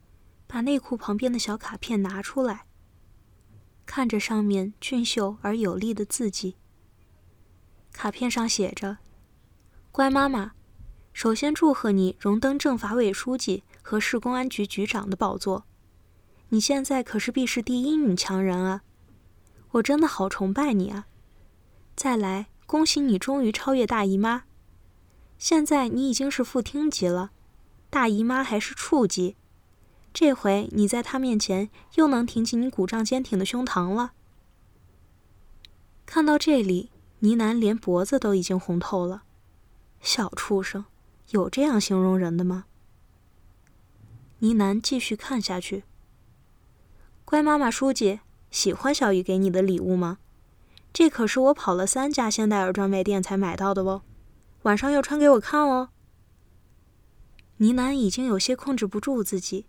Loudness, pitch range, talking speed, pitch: -25 LUFS, 180-255 Hz, 210 characters per minute, 205 Hz